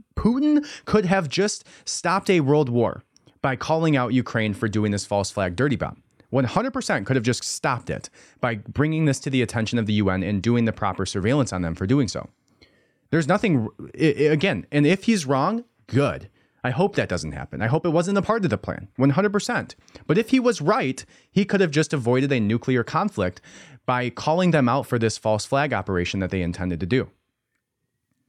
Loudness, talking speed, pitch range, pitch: -23 LUFS, 200 wpm, 110-165 Hz, 130 Hz